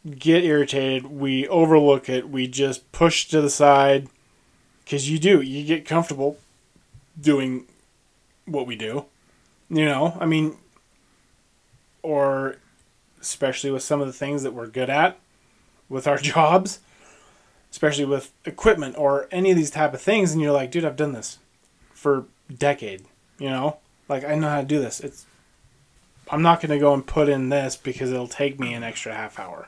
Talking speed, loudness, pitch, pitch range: 170 wpm, -22 LUFS, 140 Hz, 130-155 Hz